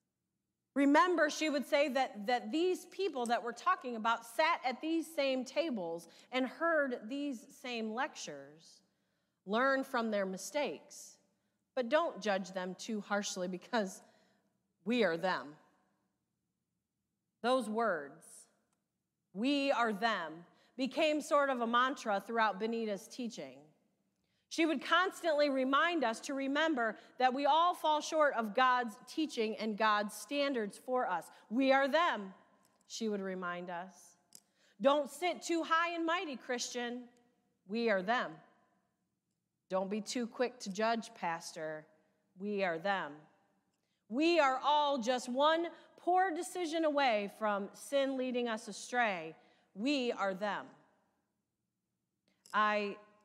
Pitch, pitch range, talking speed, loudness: 240 Hz, 205-285 Hz, 125 wpm, -34 LUFS